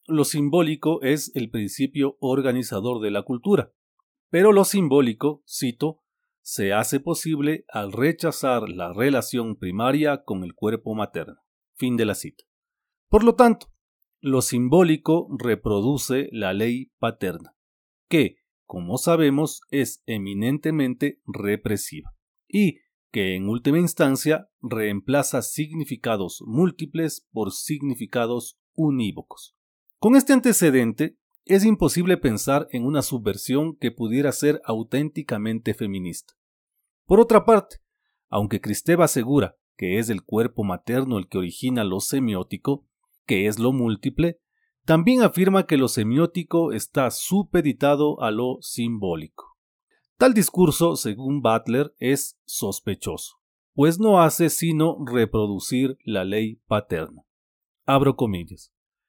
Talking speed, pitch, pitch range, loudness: 115 wpm, 140 Hz, 115-165 Hz, -22 LUFS